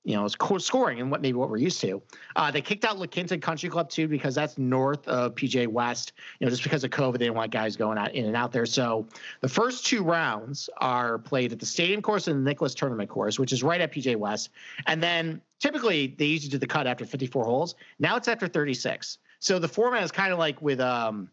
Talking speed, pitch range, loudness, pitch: 250 wpm, 125-170 Hz, -27 LUFS, 140 Hz